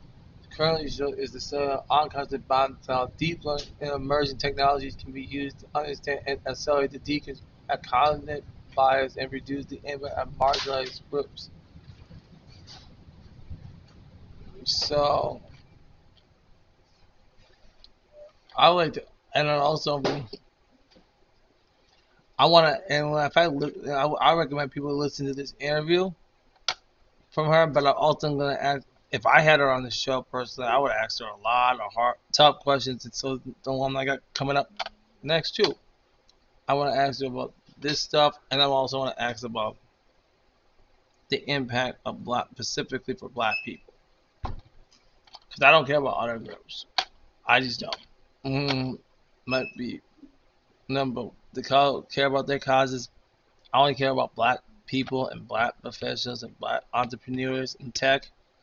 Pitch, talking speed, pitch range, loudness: 135 Hz, 150 wpm, 130-145 Hz, -26 LUFS